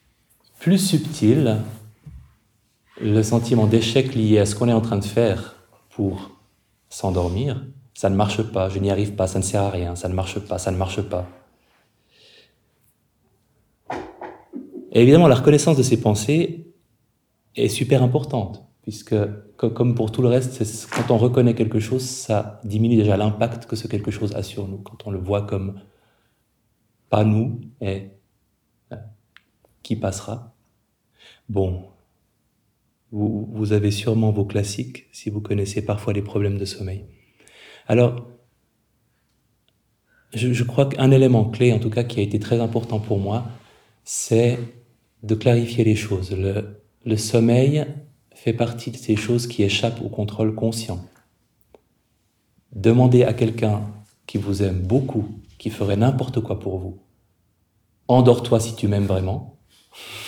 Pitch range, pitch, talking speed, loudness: 100-120 Hz, 110 Hz, 145 wpm, -21 LUFS